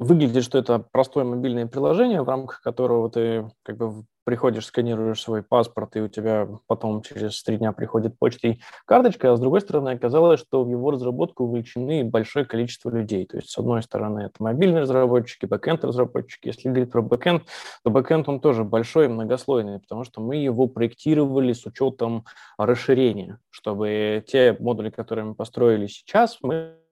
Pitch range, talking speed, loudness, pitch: 110-130 Hz, 170 wpm, -22 LUFS, 120 Hz